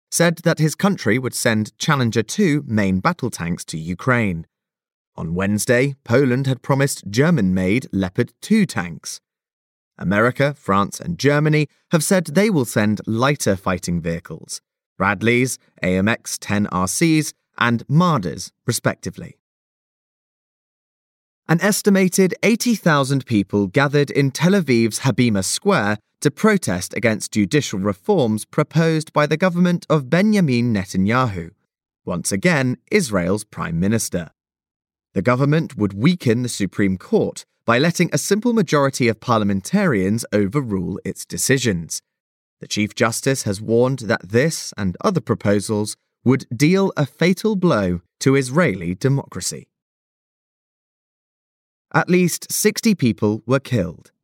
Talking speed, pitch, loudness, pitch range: 120 wpm, 130 Hz, -19 LUFS, 105-160 Hz